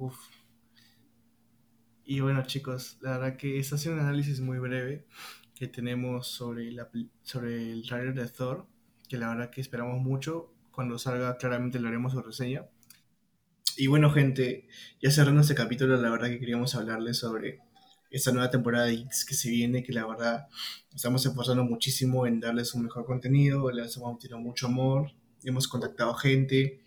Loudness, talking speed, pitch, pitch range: -29 LUFS, 170 wpm, 125 Hz, 120-135 Hz